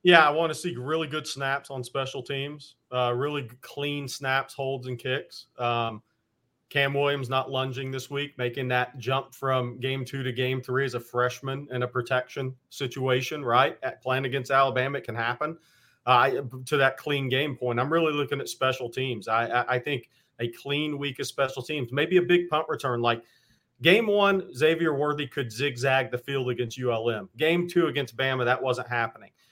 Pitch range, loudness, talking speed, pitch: 125-145 Hz, -27 LUFS, 190 wpm, 135 Hz